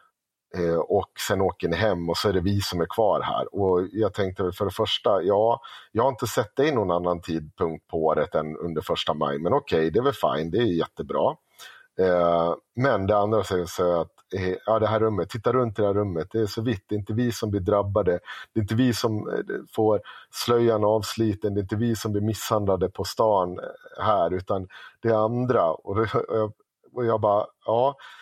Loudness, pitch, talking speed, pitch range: -25 LUFS, 105 Hz, 205 wpm, 90-110 Hz